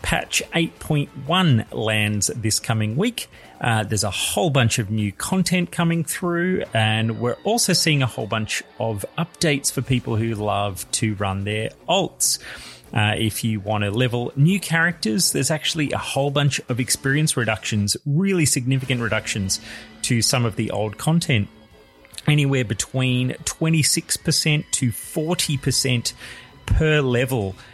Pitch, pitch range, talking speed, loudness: 125 Hz, 110-155 Hz, 140 wpm, -21 LUFS